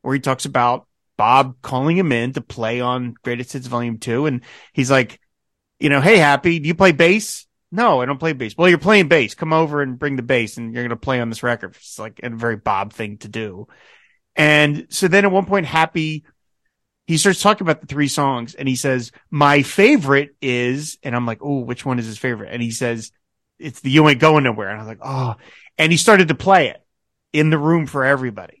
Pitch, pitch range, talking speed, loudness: 135 Hz, 120-160 Hz, 235 wpm, -17 LUFS